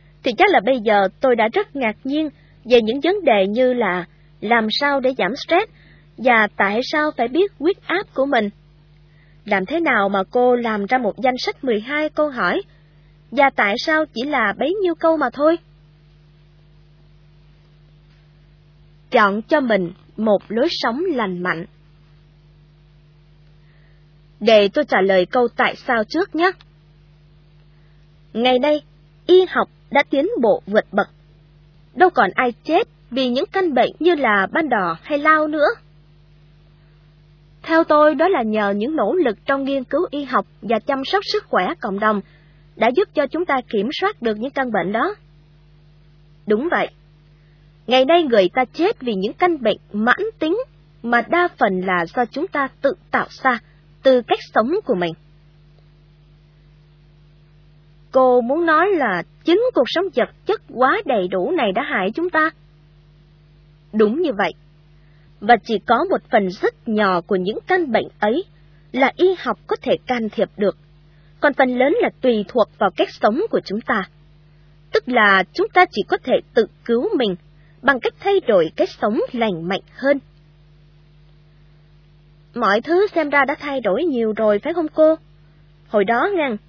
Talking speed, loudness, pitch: 165 wpm, -18 LUFS, 210 Hz